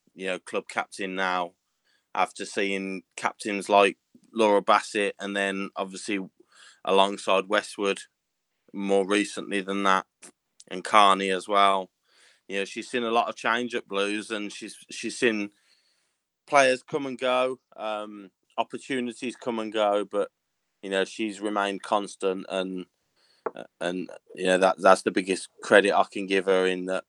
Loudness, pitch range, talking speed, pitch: -26 LUFS, 95-105 Hz, 150 wpm, 100 Hz